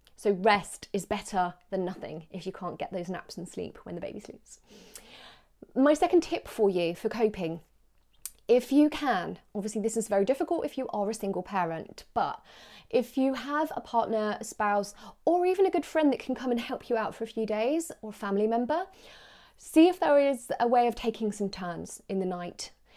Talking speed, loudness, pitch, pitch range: 210 wpm, -29 LUFS, 220 Hz, 195-275 Hz